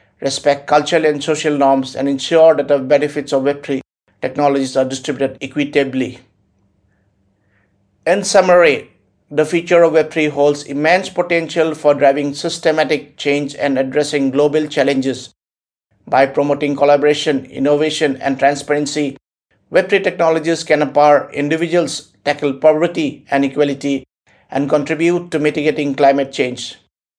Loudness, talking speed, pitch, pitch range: -15 LUFS, 120 wpm, 145 Hz, 135-155 Hz